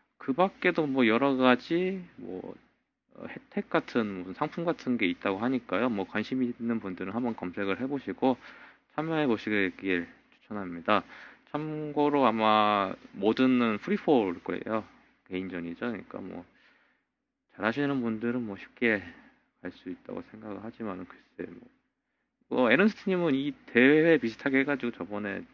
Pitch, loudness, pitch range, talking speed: 120 Hz, -28 LUFS, 105-150 Hz, 295 characters per minute